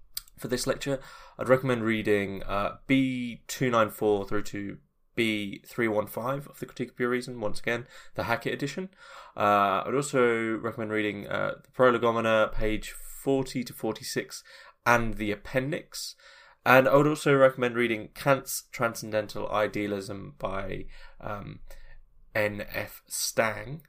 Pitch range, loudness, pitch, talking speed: 105-135 Hz, -28 LUFS, 120 Hz, 130 wpm